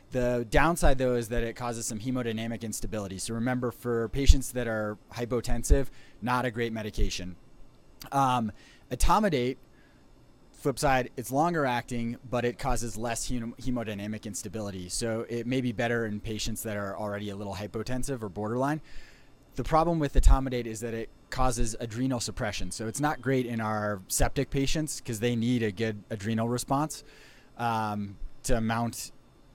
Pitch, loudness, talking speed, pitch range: 120 Hz, -30 LUFS, 160 wpm, 110-130 Hz